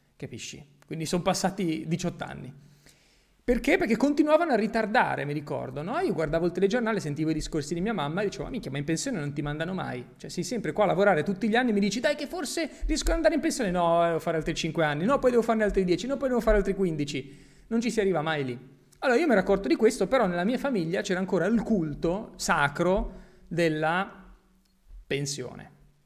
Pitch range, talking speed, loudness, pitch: 160-230 Hz, 225 wpm, -27 LUFS, 190 Hz